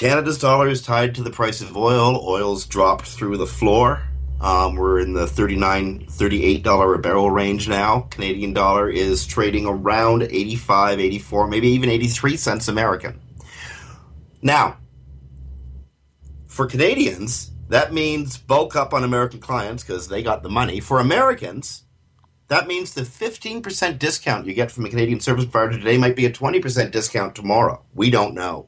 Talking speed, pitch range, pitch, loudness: 160 wpm, 95-125 Hz, 110 Hz, -19 LUFS